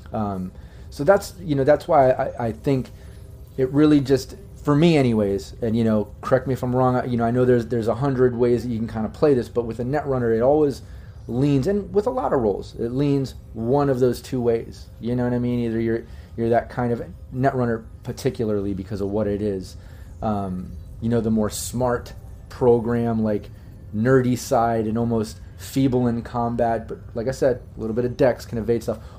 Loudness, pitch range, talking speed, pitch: -22 LUFS, 105-130 Hz, 215 wpm, 115 Hz